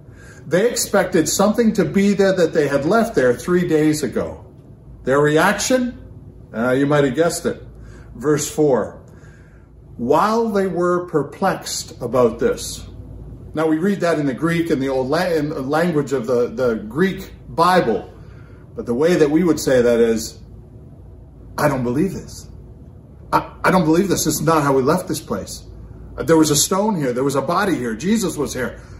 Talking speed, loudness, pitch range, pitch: 175 wpm, -18 LUFS, 125-175 Hz, 150 Hz